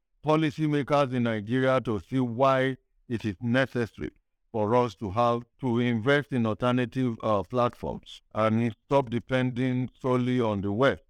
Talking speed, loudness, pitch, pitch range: 140 wpm, -27 LUFS, 125 Hz, 115-130 Hz